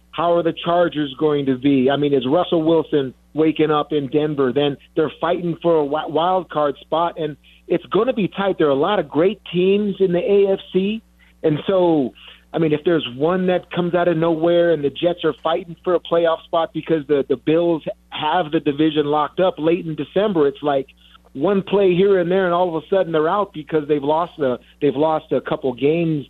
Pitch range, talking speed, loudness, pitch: 150-175 Hz, 220 wpm, -19 LUFS, 160 Hz